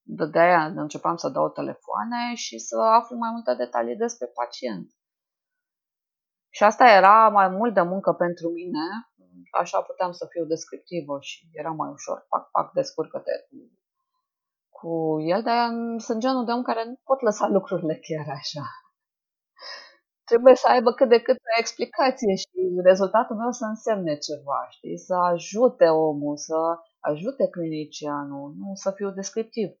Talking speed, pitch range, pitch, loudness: 150 wpm, 160-235 Hz, 195 Hz, -23 LUFS